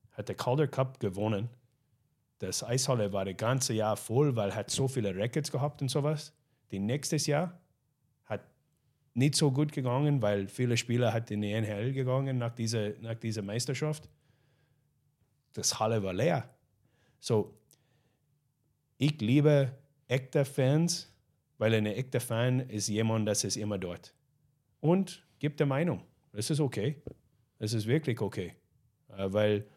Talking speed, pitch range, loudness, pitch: 145 wpm, 110-145 Hz, -31 LUFS, 125 Hz